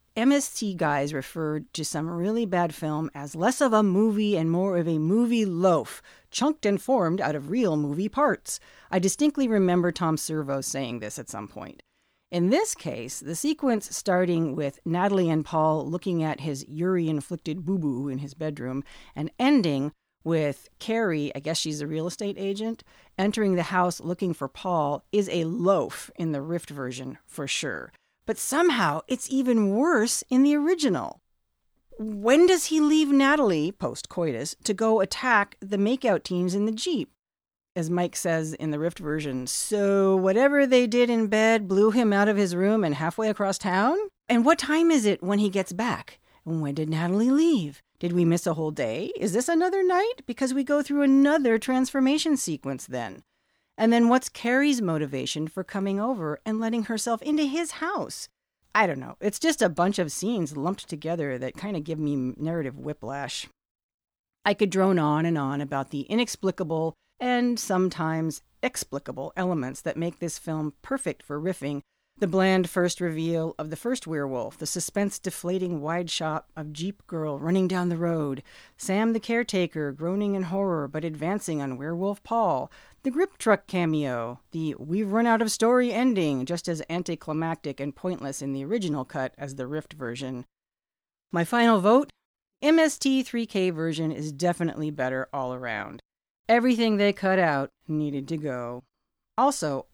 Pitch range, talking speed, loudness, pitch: 155-220 Hz, 170 wpm, -26 LUFS, 175 Hz